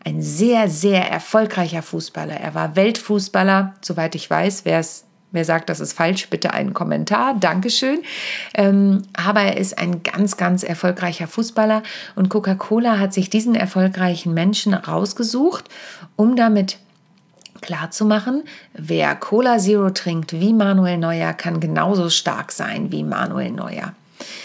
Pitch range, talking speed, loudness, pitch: 175-215 Hz, 130 wpm, -19 LUFS, 195 Hz